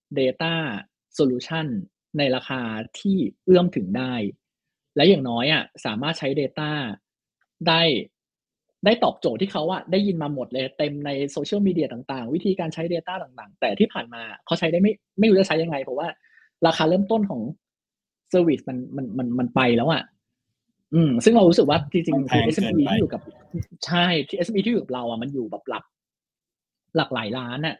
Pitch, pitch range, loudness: 160 Hz, 130-185 Hz, -23 LUFS